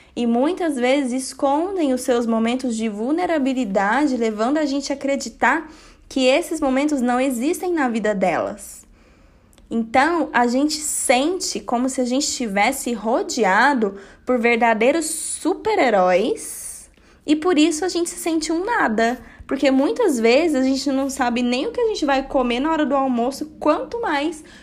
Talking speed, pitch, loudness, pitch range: 155 wpm, 270 Hz, -20 LUFS, 245-315 Hz